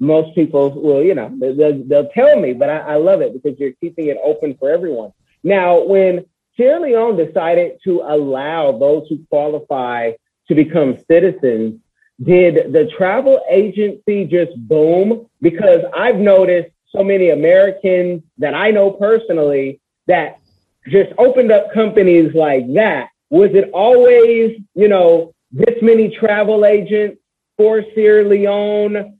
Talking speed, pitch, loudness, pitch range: 140 wpm, 190 Hz, -13 LUFS, 155-215 Hz